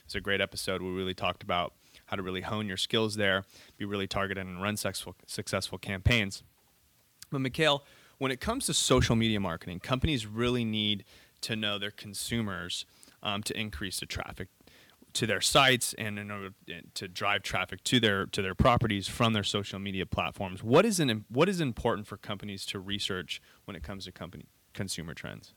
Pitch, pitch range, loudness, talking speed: 105 Hz, 95-115 Hz, -30 LUFS, 190 wpm